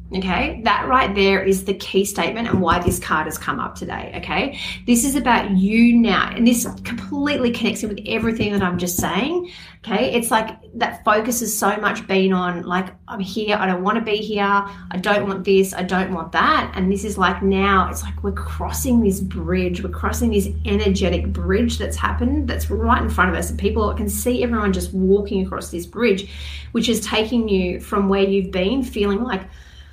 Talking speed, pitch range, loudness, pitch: 210 wpm, 180-220 Hz, -20 LUFS, 195 Hz